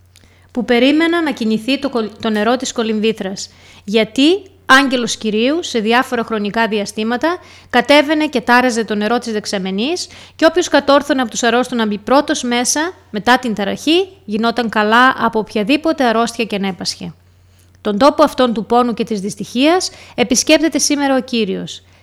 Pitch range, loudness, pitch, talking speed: 215-280 Hz, -15 LUFS, 240 Hz, 150 wpm